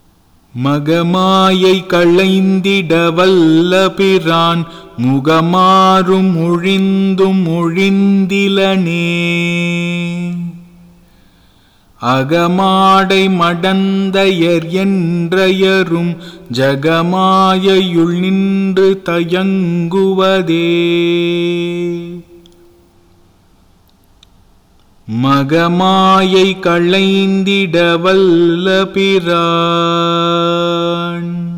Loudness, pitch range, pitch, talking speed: -11 LUFS, 170-190 Hz, 175 Hz, 30 wpm